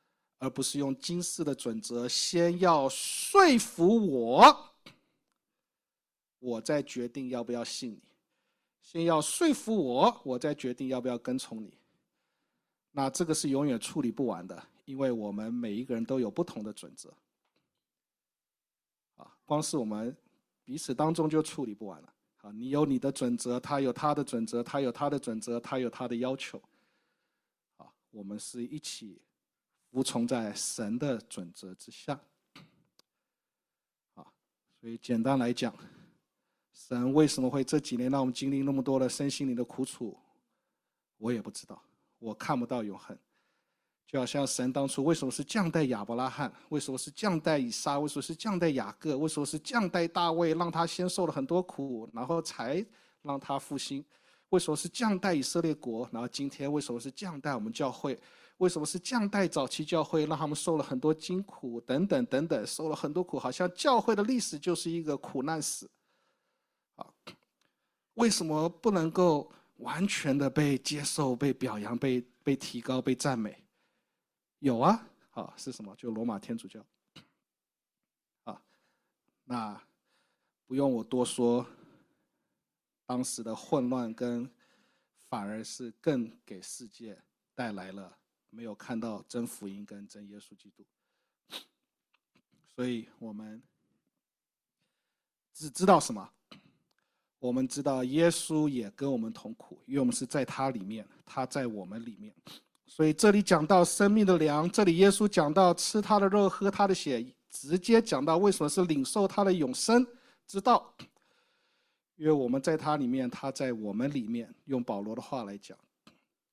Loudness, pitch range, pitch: -30 LUFS, 125-175 Hz, 140 Hz